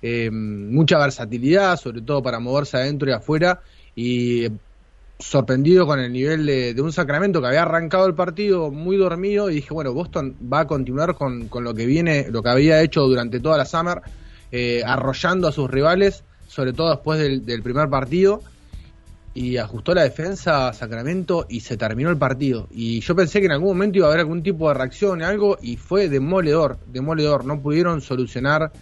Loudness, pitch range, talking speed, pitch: -20 LUFS, 125-170 Hz, 190 wpm, 145 Hz